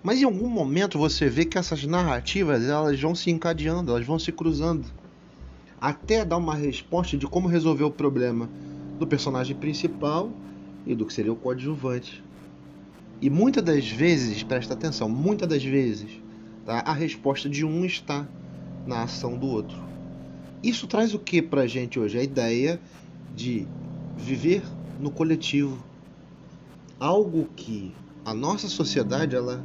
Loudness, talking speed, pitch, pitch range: -26 LUFS, 150 wpm, 150 Hz, 125-170 Hz